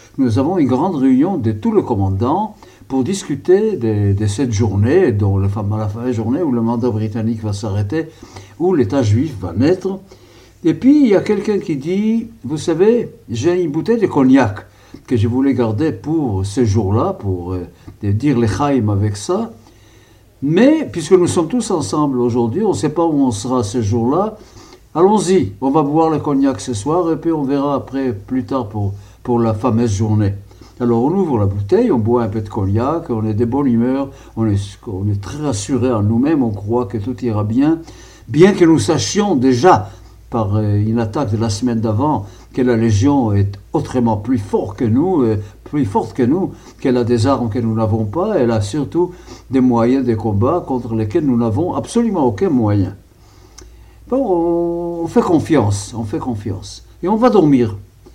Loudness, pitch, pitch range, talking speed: -16 LUFS, 120 Hz, 105-150 Hz, 195 wpm